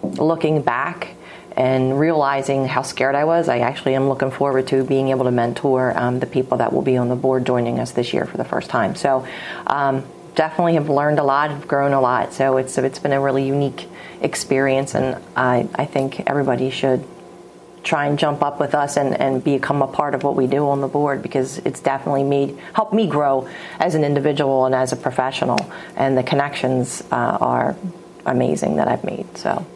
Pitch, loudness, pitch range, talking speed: 135 Hz, -19 LUFS, 130-145 Hz, 205 wpm